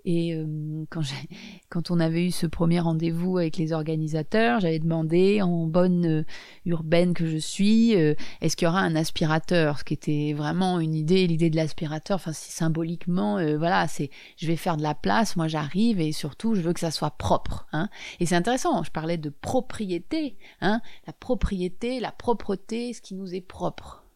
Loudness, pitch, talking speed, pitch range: -26 LUFS, 170 Hz, 195 wpm, 160-190 Hz